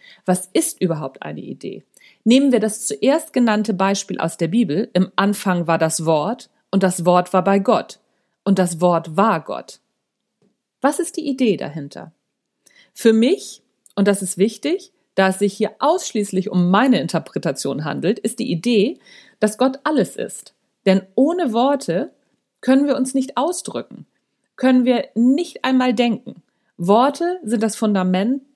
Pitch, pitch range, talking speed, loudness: 215 Hz, 190-255 Hz, 155 wpm, -19 LUFS